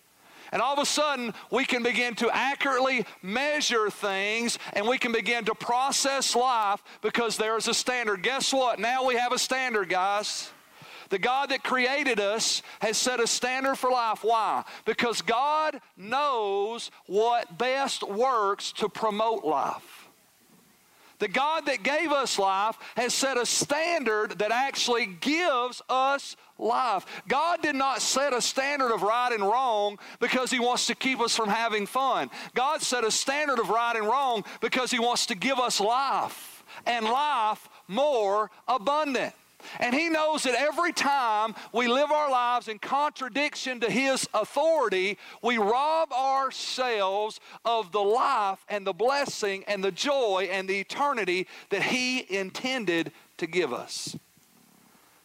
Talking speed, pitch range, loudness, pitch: 155 wpm, 215-275 Hz, -26 LUFS, 245 Hz